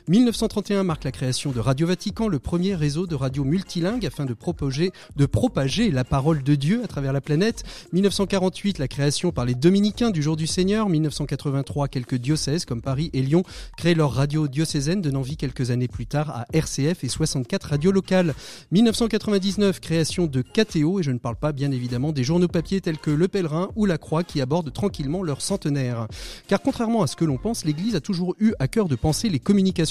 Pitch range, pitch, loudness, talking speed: 140-190 Hz, 160 Hz, -23 LUFS, 205 wpm